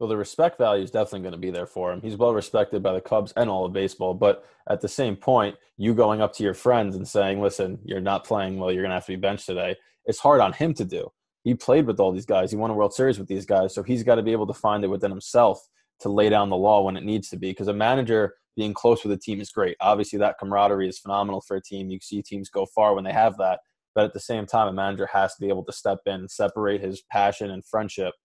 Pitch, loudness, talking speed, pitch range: 100 Hz, -24 LUFS, 290 wpm, 95-110 Hz